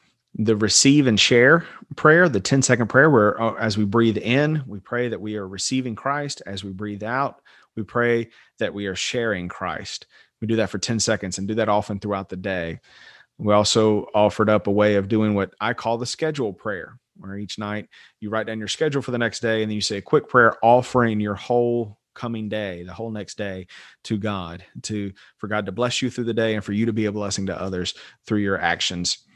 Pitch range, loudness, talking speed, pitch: 100-120 Hz, -21 LUFS, 225 wpm, 110 Hz